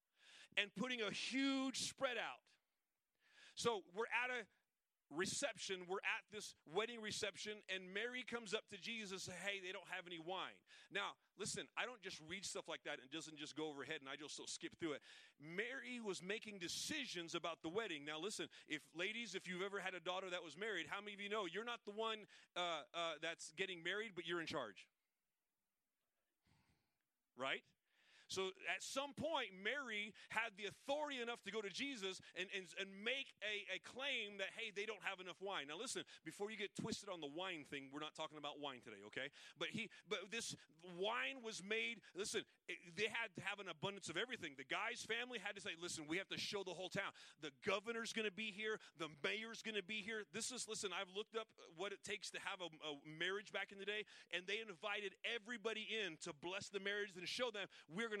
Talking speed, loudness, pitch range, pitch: 220 wpm, -47 LUFS, 180-225 Hz, 200 Hz